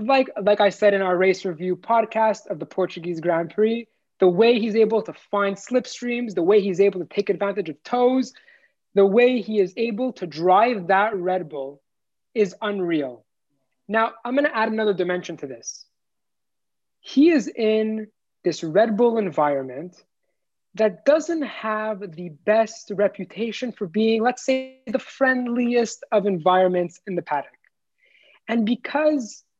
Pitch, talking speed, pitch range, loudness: 215 Hz, 155 wpm, 185-240 Hz, -22 LUFS